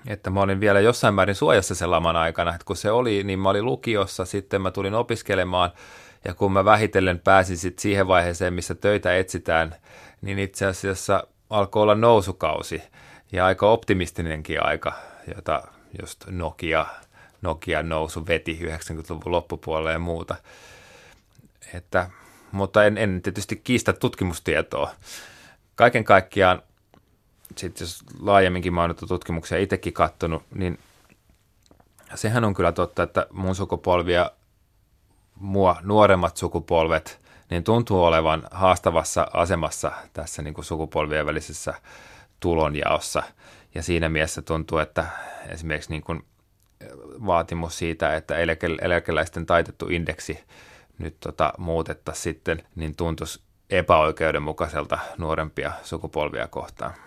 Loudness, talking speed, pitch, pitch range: -23 LUFS, 120 wpm, 90 Hz, 80-100 Hz